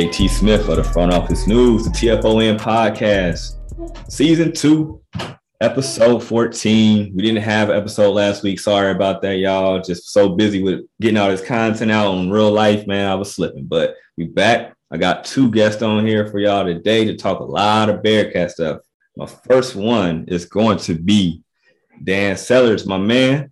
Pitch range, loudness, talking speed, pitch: 95-110 Hz, -16 LUFS, 185 wpm, 105 Hz